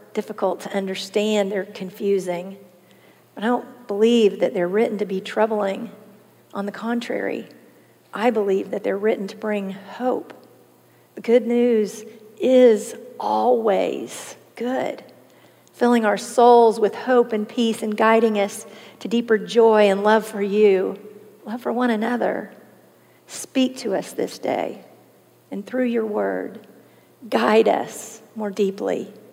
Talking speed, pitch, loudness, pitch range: 135 wpm, 215 Hz, -21 LUFS, 200-230 Hz